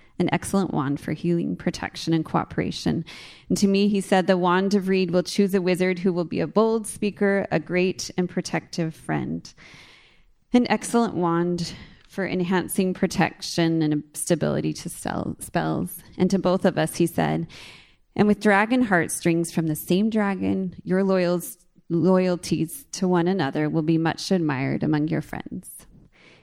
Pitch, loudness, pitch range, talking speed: 180 Hz, -23 LUFS, 160-190 Hz, 155 wpm